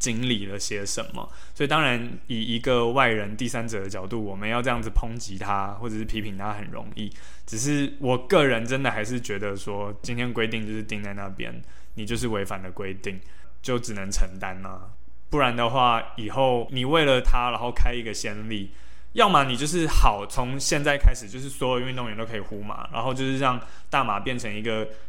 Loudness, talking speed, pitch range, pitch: -26 LUFS, 305 characters per minute, 100-125 Hz, 110 Hz